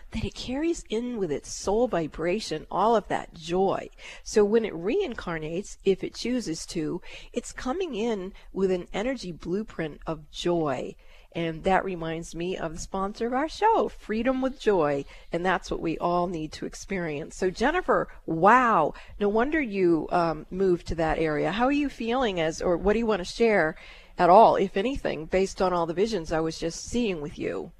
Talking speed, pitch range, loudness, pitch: 190 wpm, 165-230 Hz, -26 LUFS, 190 Hz